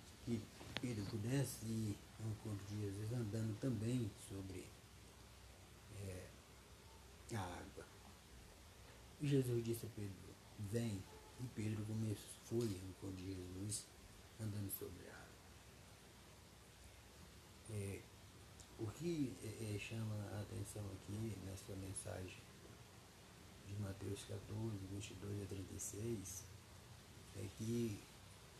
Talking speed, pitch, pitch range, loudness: 105 wpm, 100 Hz, 95-110 Hz, -47 LUFS